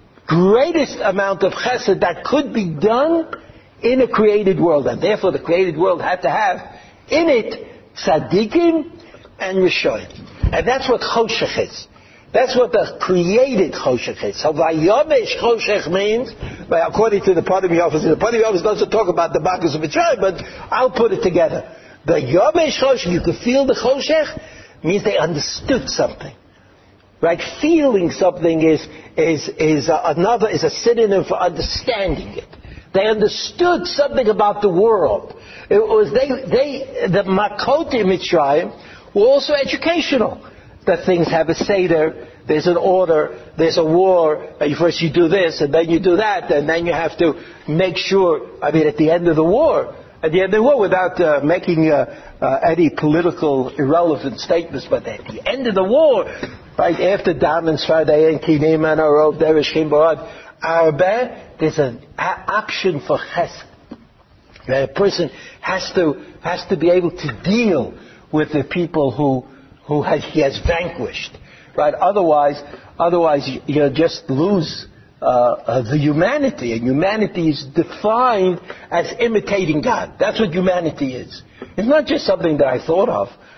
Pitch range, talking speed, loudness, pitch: 160-235 Hz, 165 wpm, -17 LUFS, 180 Hz